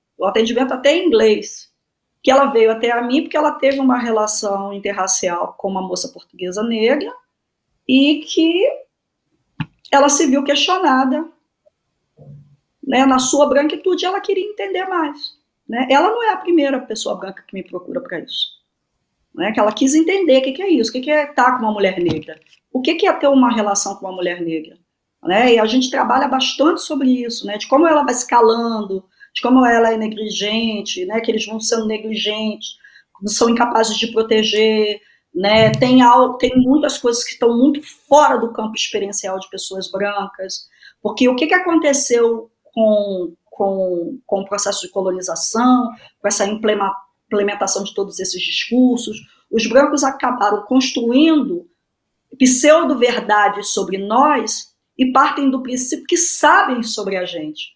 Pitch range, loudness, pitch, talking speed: 205-280 Hz, -16 LUFS, 235 Hz, 165 wpm